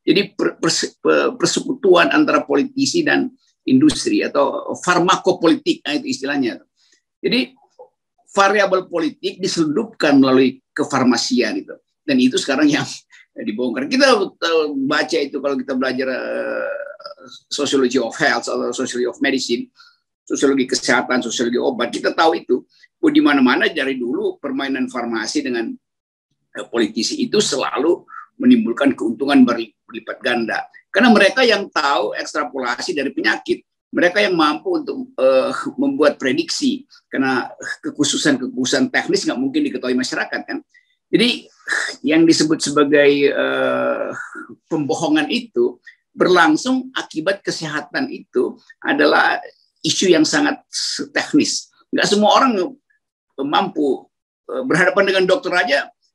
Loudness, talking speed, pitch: -18 LUFS, 110 wpm, 265 Hz